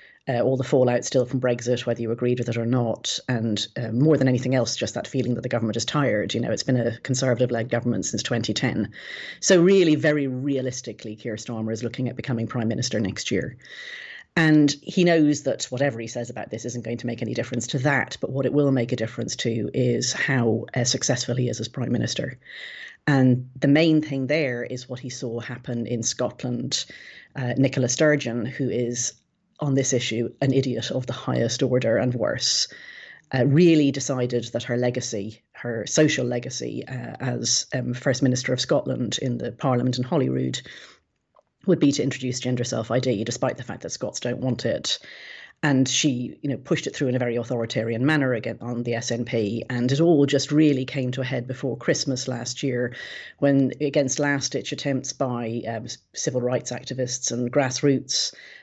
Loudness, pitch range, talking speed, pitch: -24 LUFS, 120-140 Hz, 195 wpm, 125 Hz